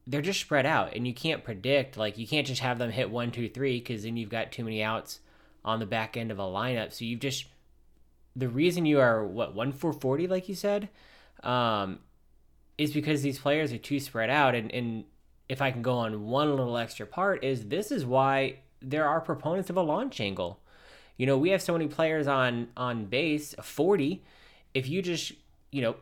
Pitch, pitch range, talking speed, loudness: 130 Hz, 115-150 Hz, 215 wpm, -29 LUFS